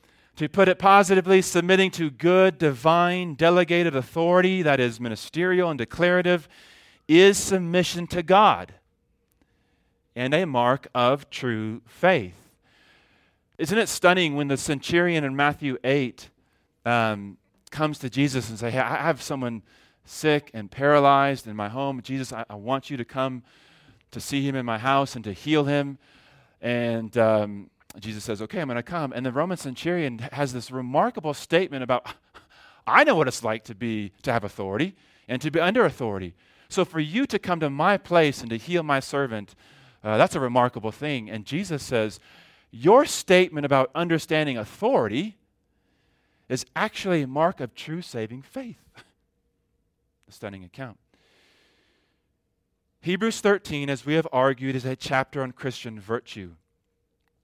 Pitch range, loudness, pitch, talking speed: 115-165 Hz, -23 LUFS, 135 Hz, 155 wpm